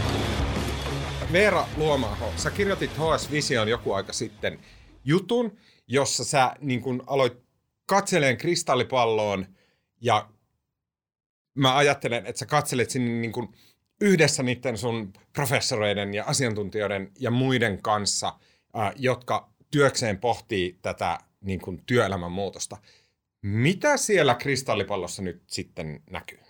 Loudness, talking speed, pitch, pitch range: -25 LUFS, 105 wpm, 125 Hz, 100-140 Hz